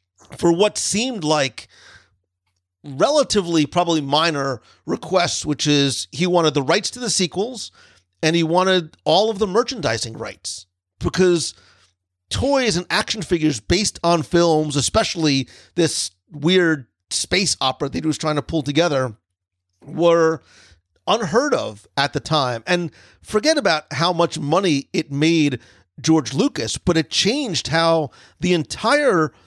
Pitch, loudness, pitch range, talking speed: 155 Hz, -19 LUFS, 125-175 Hz, 135 wpm